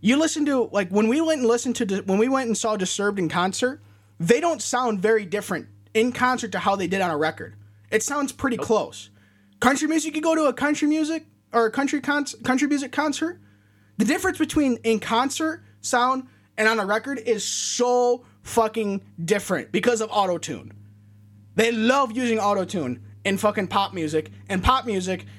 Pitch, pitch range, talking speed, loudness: 220 Hz, 185-260 Hz, 185 wpm, -23 LUFS